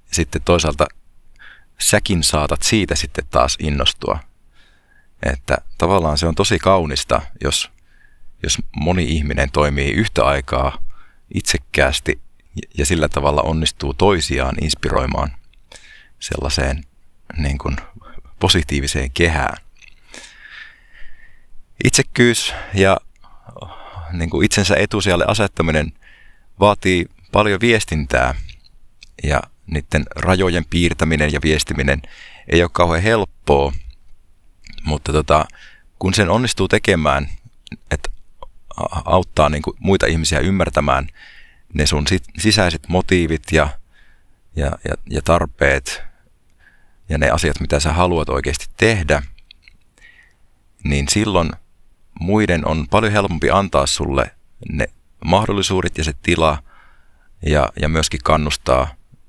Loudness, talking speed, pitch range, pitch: -17 LUFS, 100 wpm, 70-90 Hz, 80 Hz